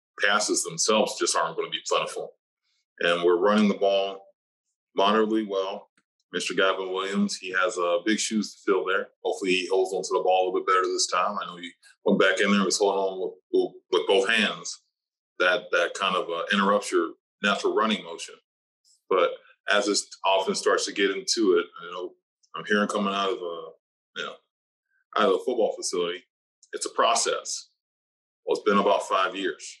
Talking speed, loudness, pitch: 200 wpm, -25 LUFS, 390 Hz